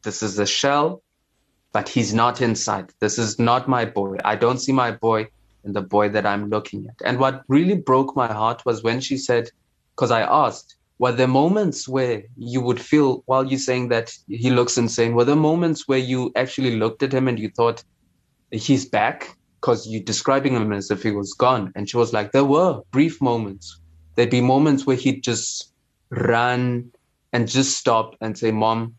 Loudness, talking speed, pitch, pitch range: -21 LUFS, 200 wpm, 120 Hz, 110-130 Hz